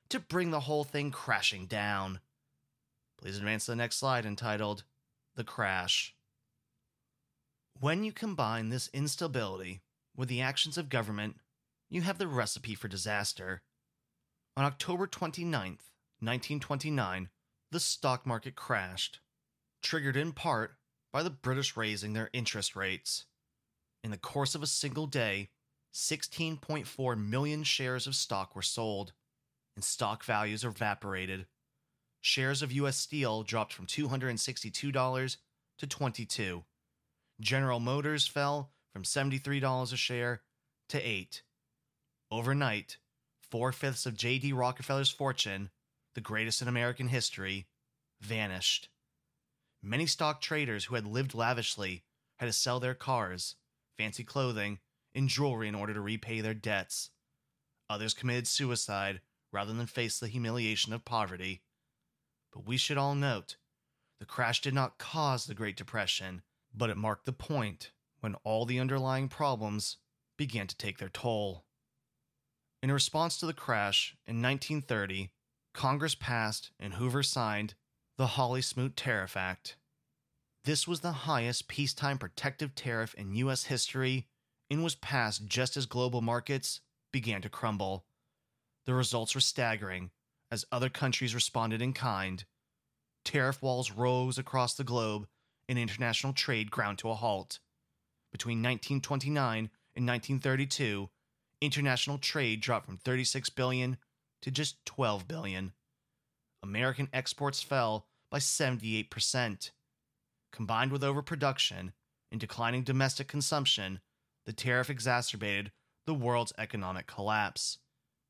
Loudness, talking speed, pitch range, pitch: -34 LUFS, 125 wpm, 110-140 Hz, 125 Hz